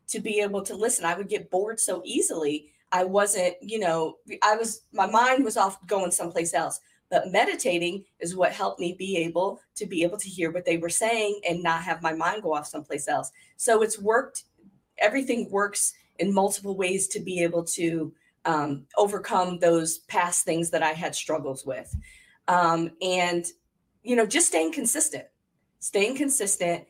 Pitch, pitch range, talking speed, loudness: 185 Hz, 170-210 Hz, 180 wpm, -25 LUFS